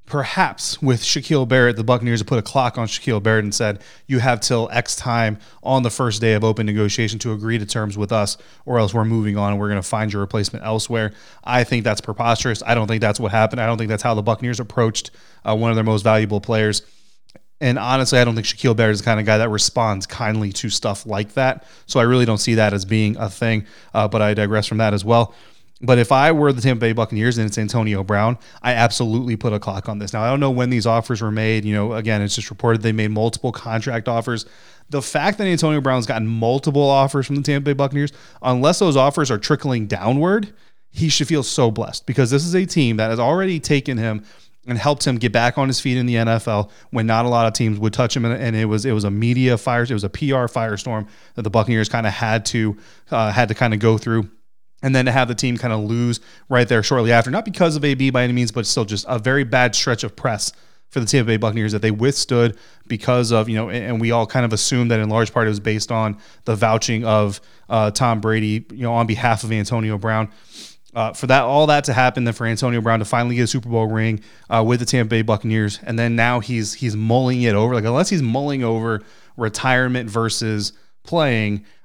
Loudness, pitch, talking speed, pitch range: -19 LUFS, 115 Hz, 245 wpm, 110-125 Hz